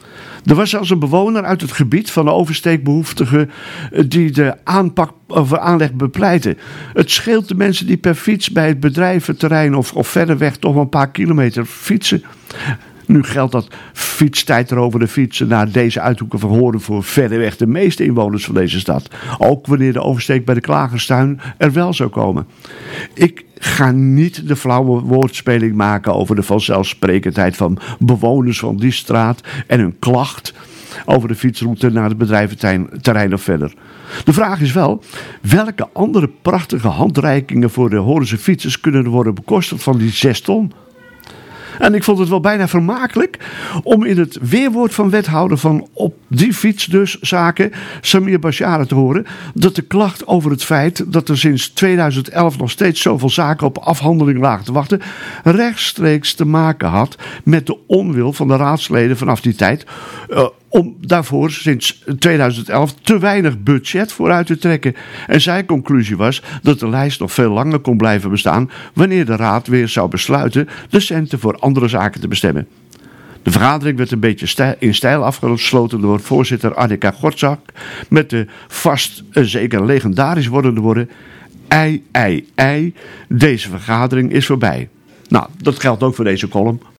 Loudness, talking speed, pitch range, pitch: -14 LUFS, 170 wpm, 120-170 Hz, 140 Hz